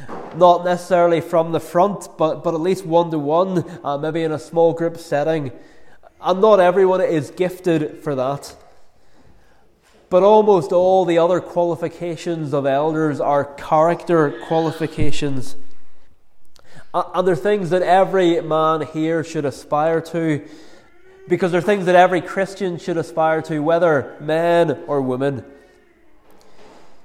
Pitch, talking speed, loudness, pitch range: 165 Hz, 130 wpm, -18 LUFS, 155-180 Hz